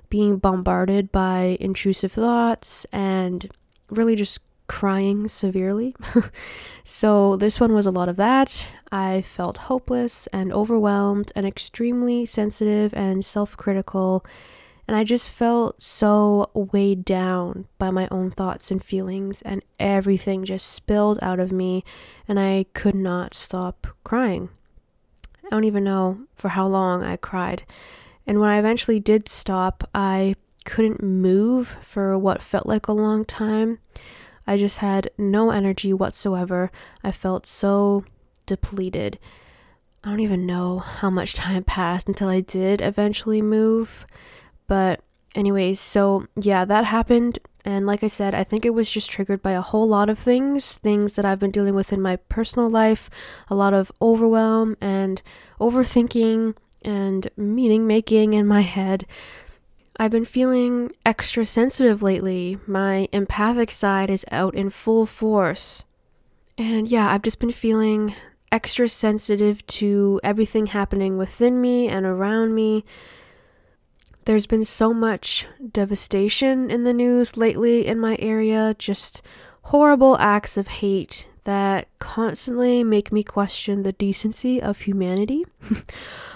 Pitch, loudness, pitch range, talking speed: 205 Hz, -21 LUFS, 195-225 Hz, 140 wpm